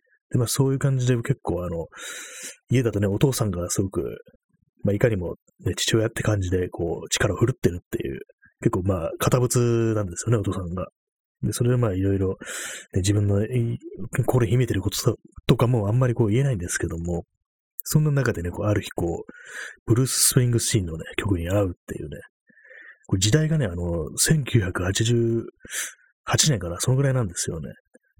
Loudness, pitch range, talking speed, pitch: -24 LUFS, 95-125 Hz, 350 characters per minute, 115 Hz